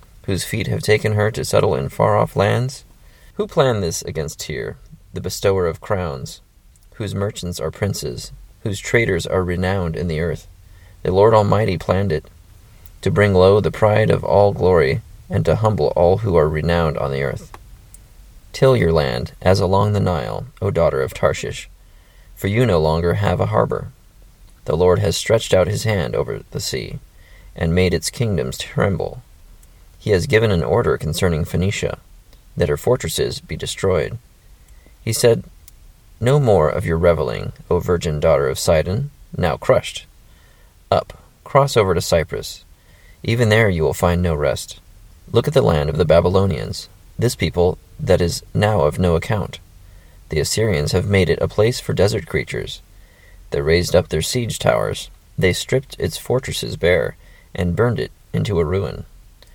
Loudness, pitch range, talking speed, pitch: -19 LUFS, 85-105 Hz, 170 wpm, 90 Hz